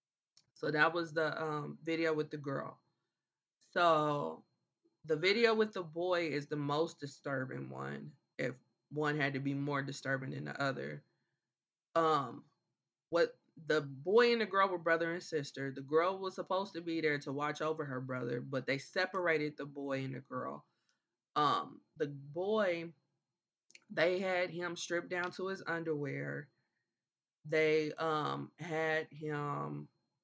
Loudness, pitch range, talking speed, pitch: -36 LUFS, 140-170 Hz, 150 wpm, 155 Hz